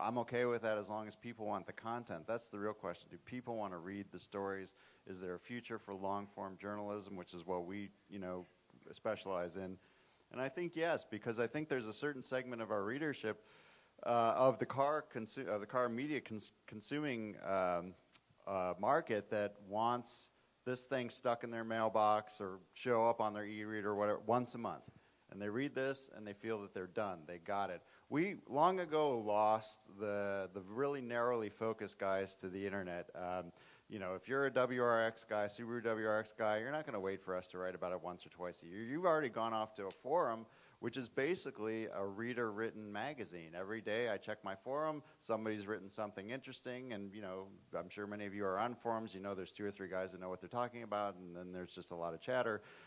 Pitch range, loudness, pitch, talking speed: 95-120 Hz, -41 LUFS, 105 Hz, 220 wpm